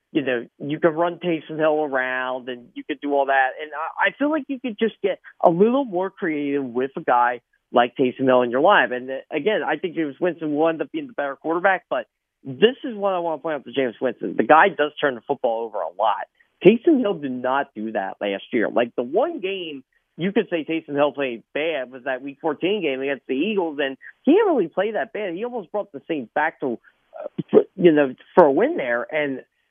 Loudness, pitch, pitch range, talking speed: -22 LUFS, 155 Hz, 130-190 Hz, 240 wpm